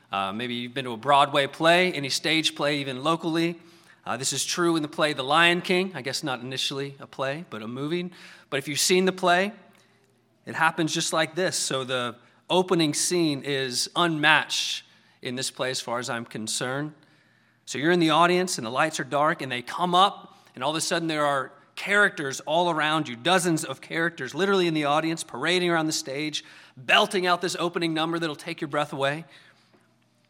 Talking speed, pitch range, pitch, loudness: 205 wpm, 135-170 Hz, 155 Hz, -24 LUFS